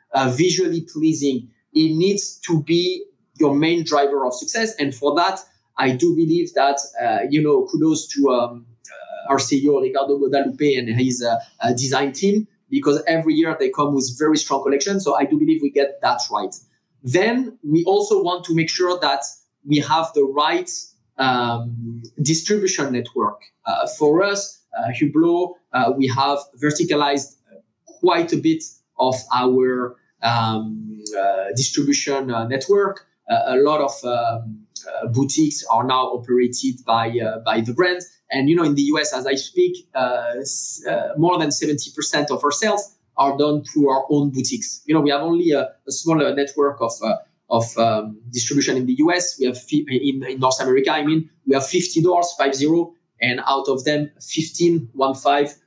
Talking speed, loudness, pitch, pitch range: 175 wpm, -20 LUFS, 145 Hz, 130-175 Hz